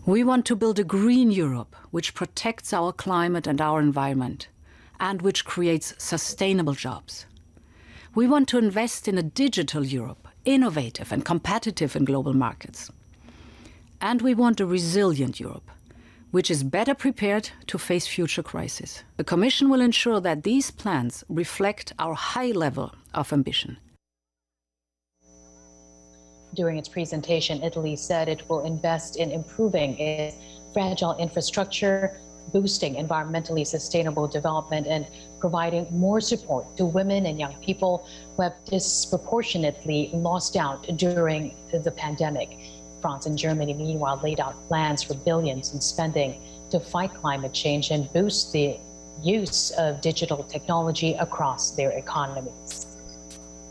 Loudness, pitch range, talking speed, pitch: -25 LUFS, 135-185 Hz, 135 wpm, 160 Hz